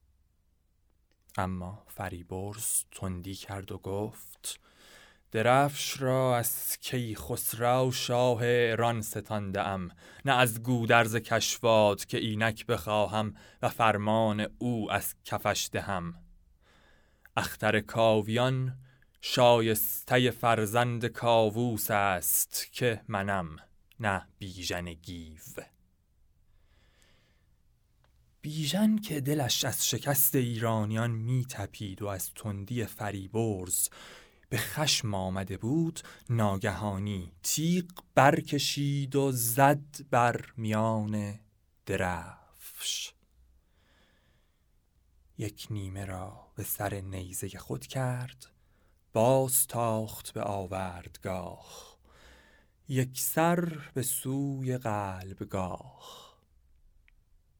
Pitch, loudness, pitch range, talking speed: 110 Hz, -30 LUFS, 95-120 Hz, 85 wpm